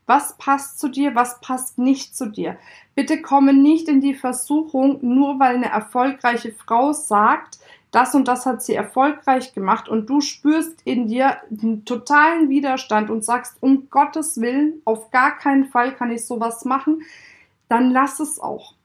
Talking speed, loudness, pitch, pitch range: 170 wpm, -19 LUFS, 265 Hz, 240-285 Hz